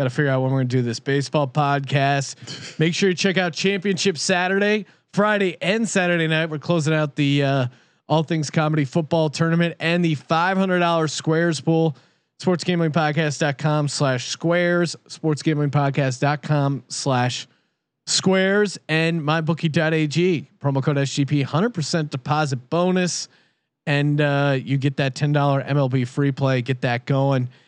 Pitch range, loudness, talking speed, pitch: 140-170 Hz, -21 LUFS, 150 wpm, 155 Hz